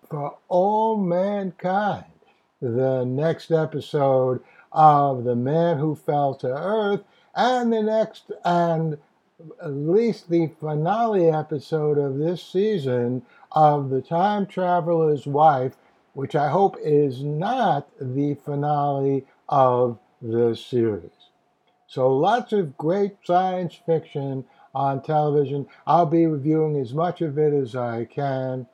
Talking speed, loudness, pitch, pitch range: 120 wpm, -22 LUFS, 150 Hz, 135-175 Hz